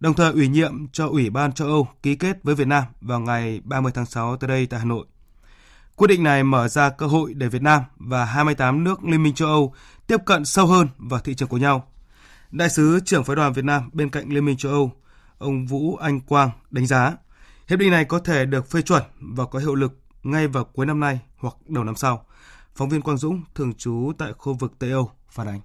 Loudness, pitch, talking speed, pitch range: -21 LUFS, 140 Hz, 240 wpm, 130-155 Hz